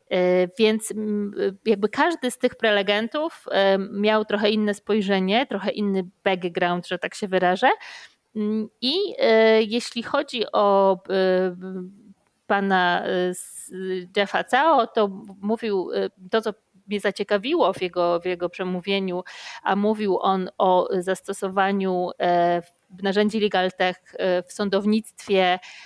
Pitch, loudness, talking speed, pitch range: 195 Hz, -23 LUFS, 105 wpm, 185-215 Hz